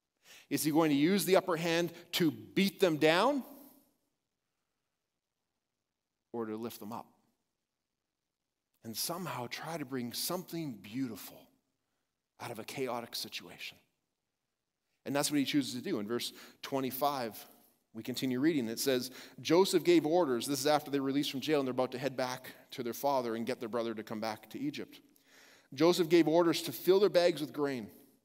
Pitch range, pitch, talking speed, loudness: 125-175 Hz, 145 Hz, 170 wpm, -33 LUFS